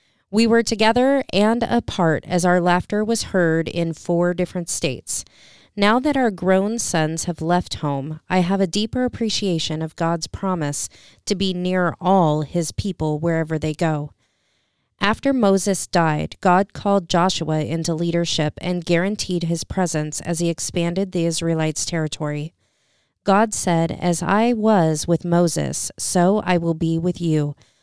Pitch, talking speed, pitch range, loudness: 175 Hz, 150 wpm, 160-195 Hz, -20 LUFS